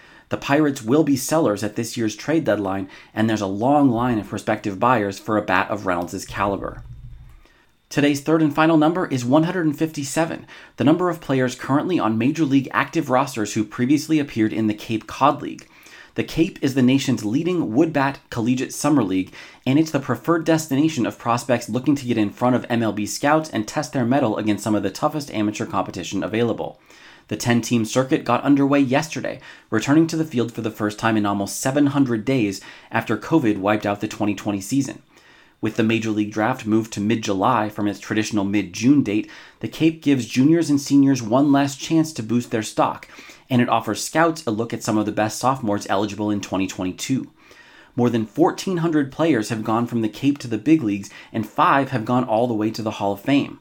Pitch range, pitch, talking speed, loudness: 105-140 Hz, 120 Hz, 205 wpm, -21 LUFS